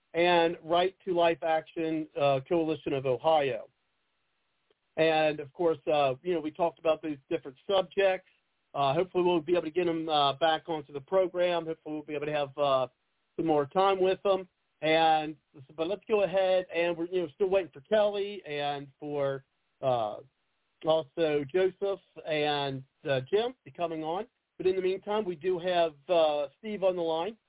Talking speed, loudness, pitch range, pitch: 185 wpm, -29 LUFS, 150-185 Hz, 165 Hz